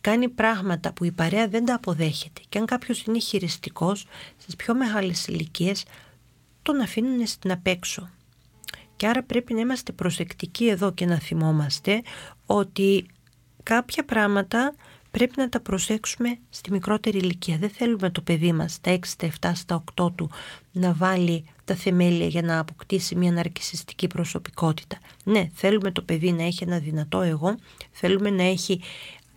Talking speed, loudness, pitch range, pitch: 155 wpm, -25 LUFS, 170-215 Hz, 185 Hz